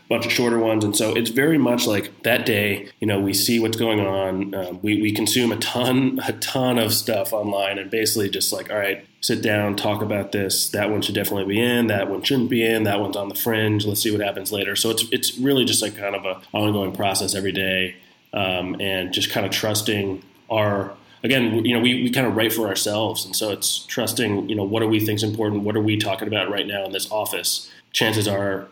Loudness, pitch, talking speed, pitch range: -21 LUFS, 105 Hz, 240 wpm, 100-115 Hz